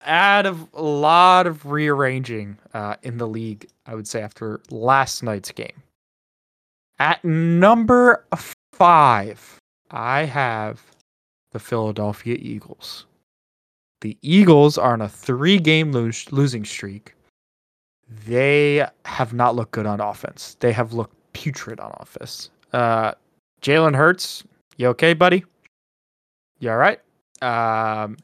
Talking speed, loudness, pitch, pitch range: 125 wpm, -18 LUFS, 125 Hz, 110-160 Hz